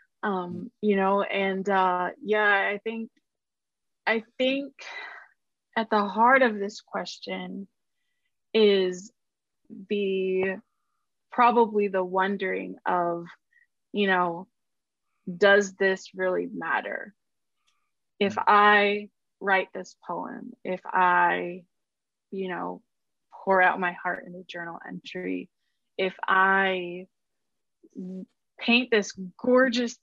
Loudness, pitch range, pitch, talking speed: -25 LUFS, 185-235 Hz, 200 Hz, 100 wpm